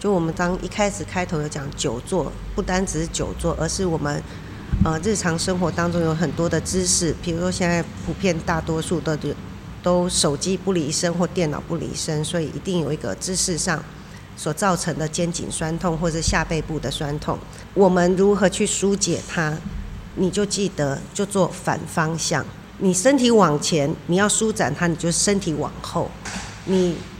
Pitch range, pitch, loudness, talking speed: 160-185 Hz, 170 Hz, -22 LUFS, 265 characters per minute